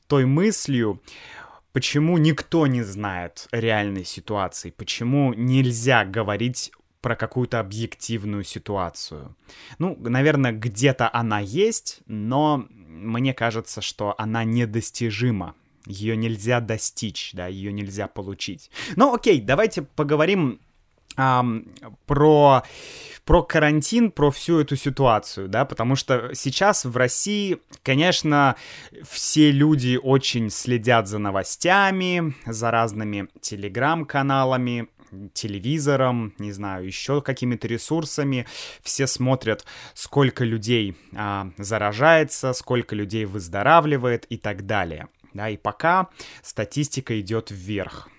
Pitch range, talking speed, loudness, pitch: 105-140 Hz, 105 wpm, -22 LUFS, 120 Hz